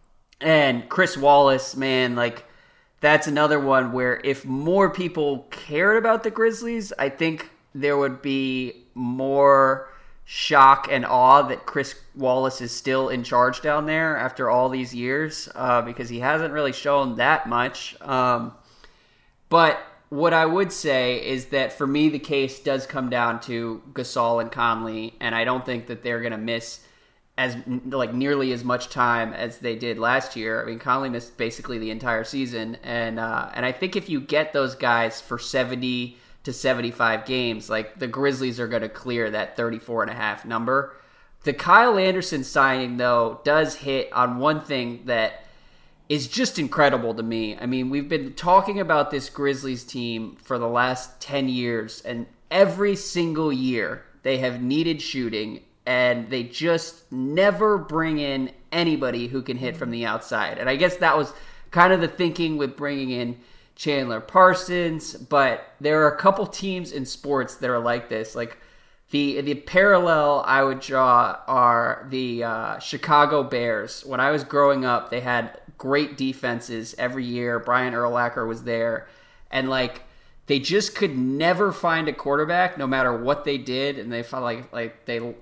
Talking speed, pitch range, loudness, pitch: 170 wpm, 120-145 Hz, -22 LUFS, 130 Hz